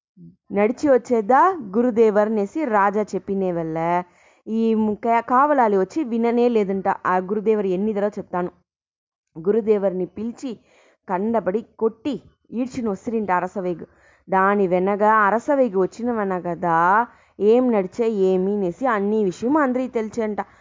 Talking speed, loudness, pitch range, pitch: 105 wpm, -21 LUFS, 190-235 Hz, 215 Hz